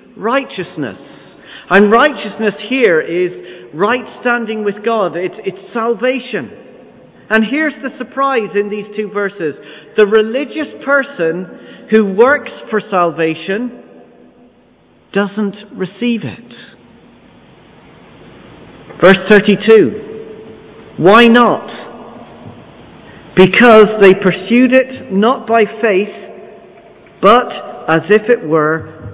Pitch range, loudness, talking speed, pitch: 195-245 Hz, -12 LUFS, 95 wpm, 215 Hz